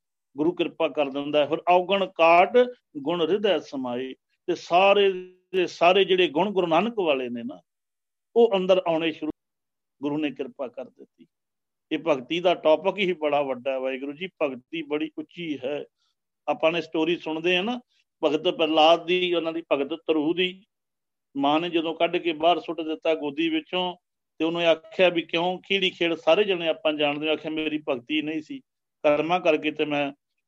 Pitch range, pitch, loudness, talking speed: 155-180 Hz, 165 Hz, -24 LUFS, 175 wpm